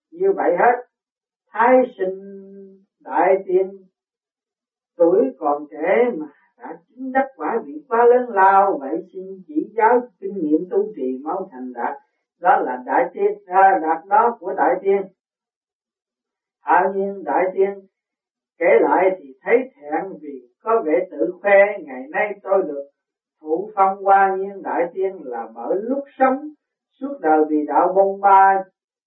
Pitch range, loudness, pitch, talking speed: 185-245 Hz, -19 LUFS, 195 Hz, 155 wpm